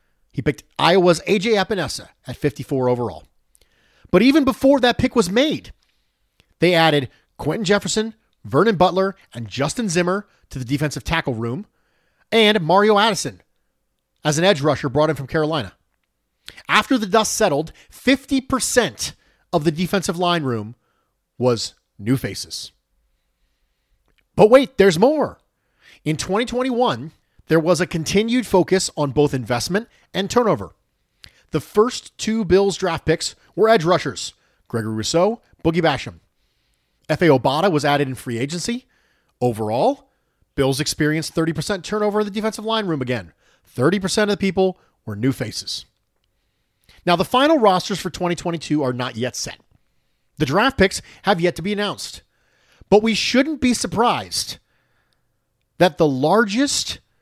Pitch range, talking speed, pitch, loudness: 135-210 Hz, 140 wpm, 175 Hz, -19 LUFS